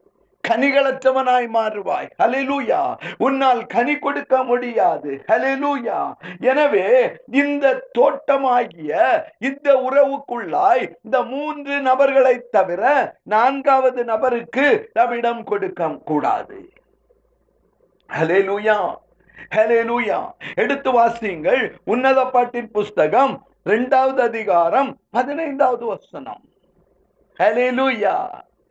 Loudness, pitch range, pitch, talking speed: -18 LUFS, 230-280 Hz, 255 Hz, 70 wpm